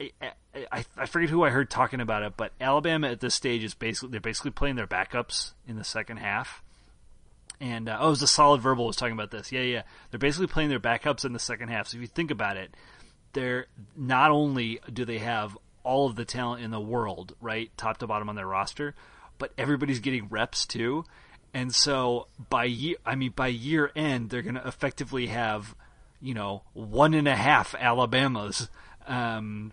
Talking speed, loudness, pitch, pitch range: 205 wpm, -28 LUFS, 125 Hz, 115-135 Hz